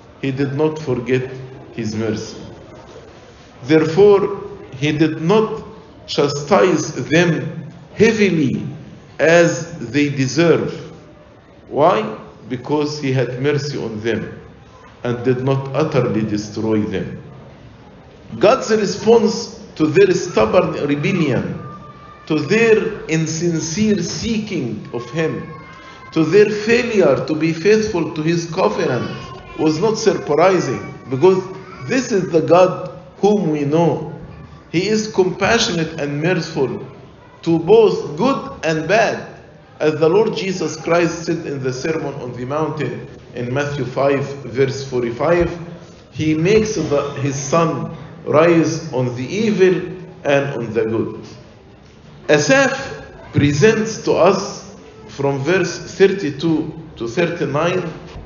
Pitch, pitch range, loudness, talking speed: 160 Hz, 145-185 Hz, -17 LUFS, 115 wpm